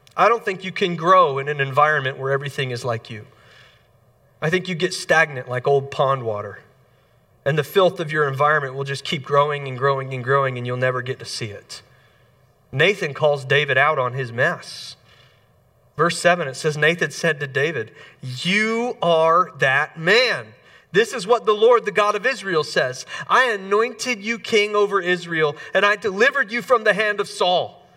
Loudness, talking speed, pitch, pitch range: -20 LUFS, 190 wpm, 150 Hz, 130-190 Hz